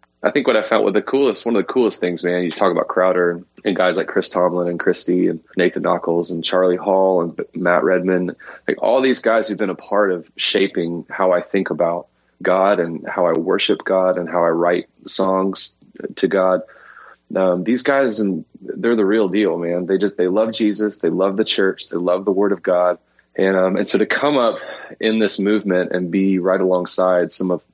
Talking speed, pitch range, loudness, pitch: 220 wpm, 90-95 Hz, -18 LUFS, 90 Hz